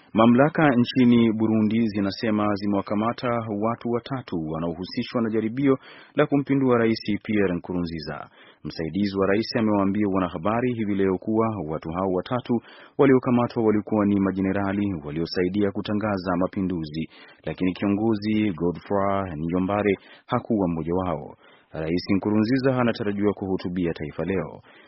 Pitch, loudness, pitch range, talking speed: 100 Hz, -24 LUFS, 90-115 Hz, 110 wpm